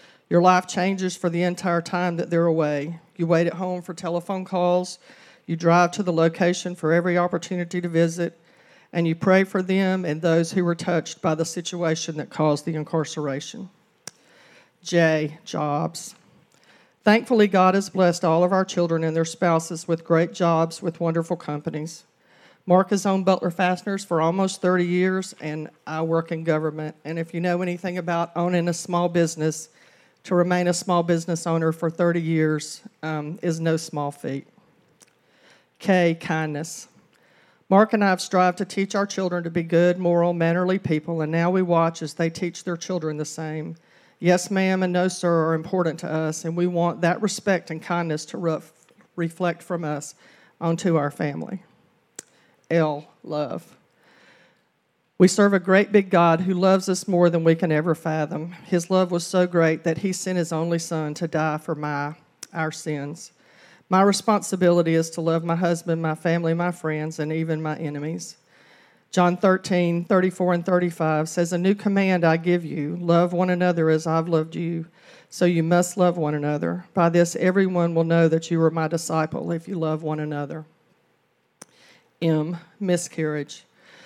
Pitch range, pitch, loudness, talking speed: 160-180 Hz, 170 Hz, -23 LUFS, 175 wpm